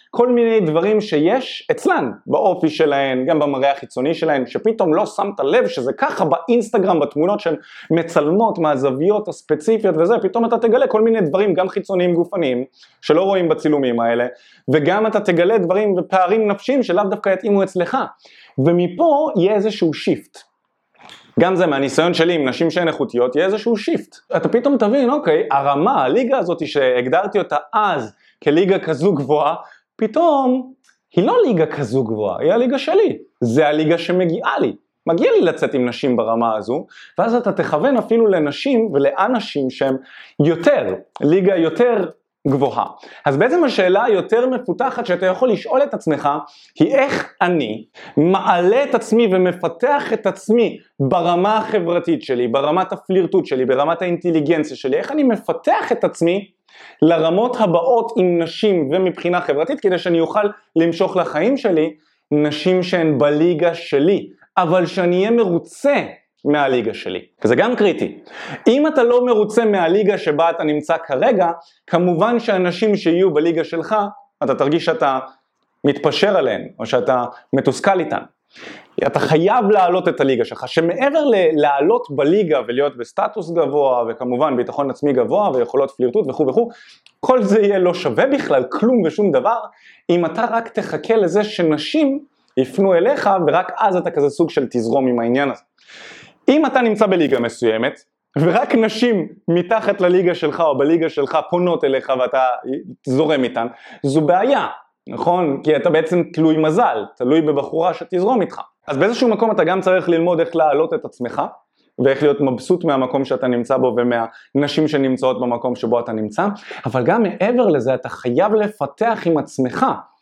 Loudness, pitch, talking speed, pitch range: -17 LUFS, 175 Hz, 150 wpm, 150-220 Hz